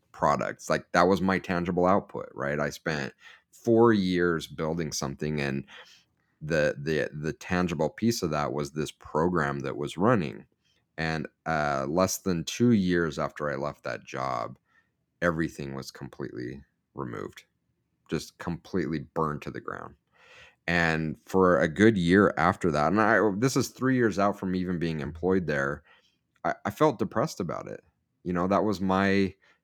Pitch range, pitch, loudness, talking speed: 75-100 Hz, 90 Hz, -27 LUFS, 160 wpm